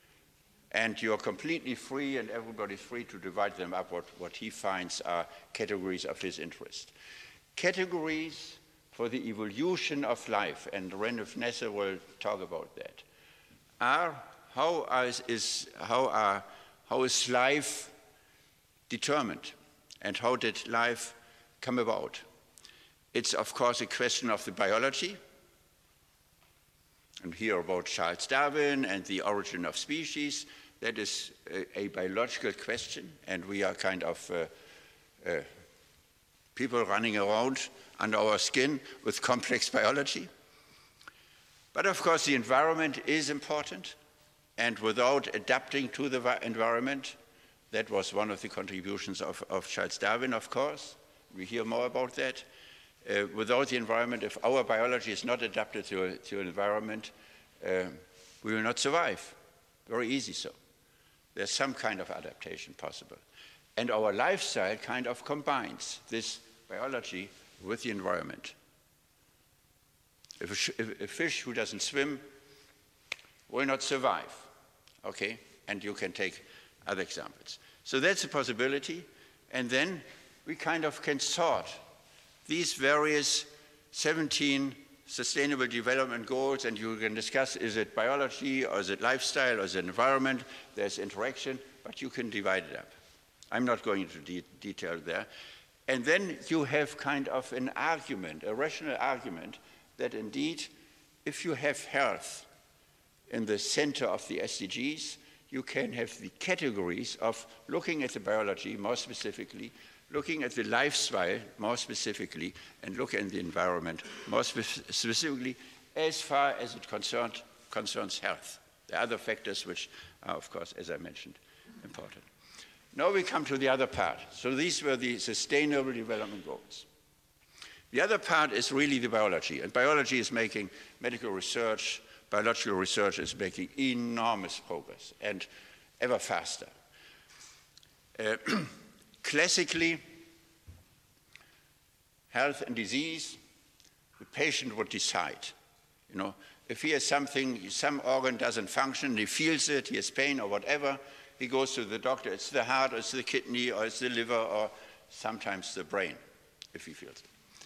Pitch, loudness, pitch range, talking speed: 130 Hz, -32 LUFS, 110-145 Hz, 140 wpm